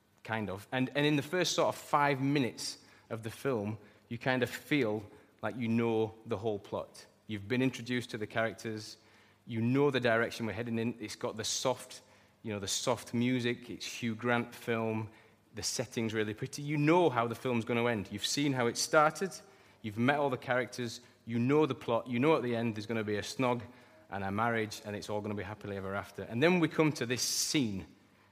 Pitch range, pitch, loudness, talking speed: 110-130 Hz, 115 Hz, -33 LUFS, 225 wpm